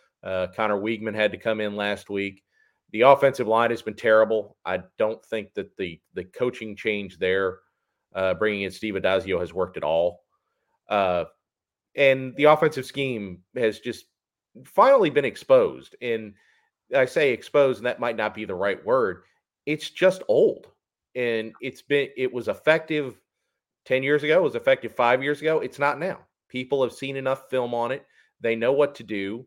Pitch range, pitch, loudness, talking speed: 110-140 Hz, 120 Hz, -24 LUFS, 180 wpm